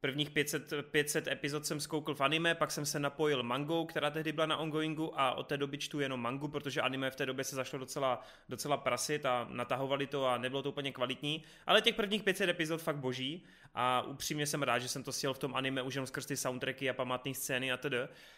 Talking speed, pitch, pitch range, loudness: 230 wpm, 145 Hz, 135-155 Hz, -35 LUFS